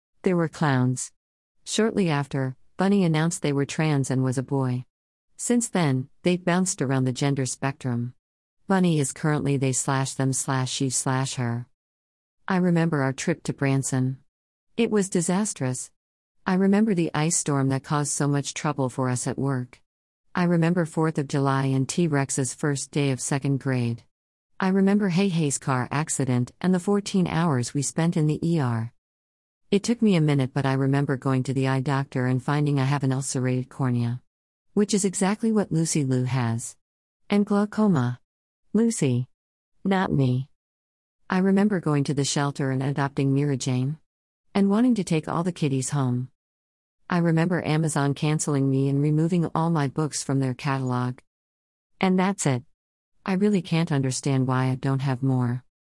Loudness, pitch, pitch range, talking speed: -24 LUFS, 140 Hz, 130-165 Hz, 170 wpm